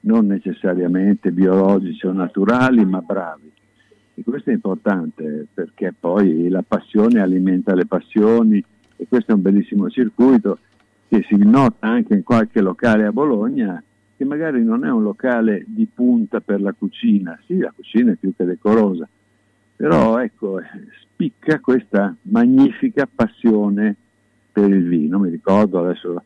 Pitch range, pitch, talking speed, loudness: 95-135 Hz, 105 Hz, 145 wpm, -17 LUFS